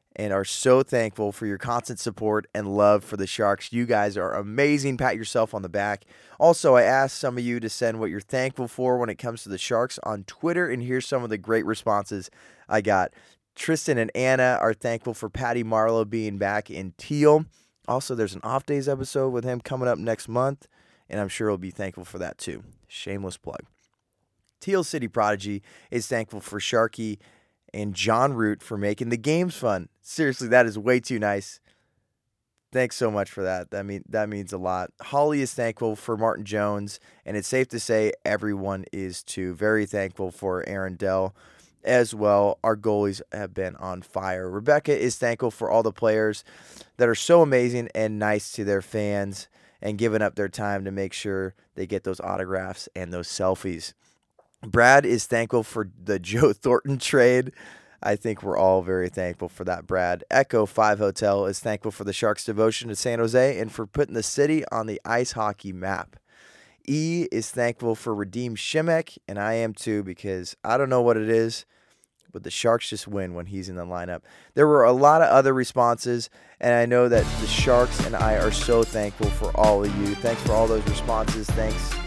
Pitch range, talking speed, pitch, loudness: 100-120 Hz, 195 wpm, 110 Hz, -24 LUFS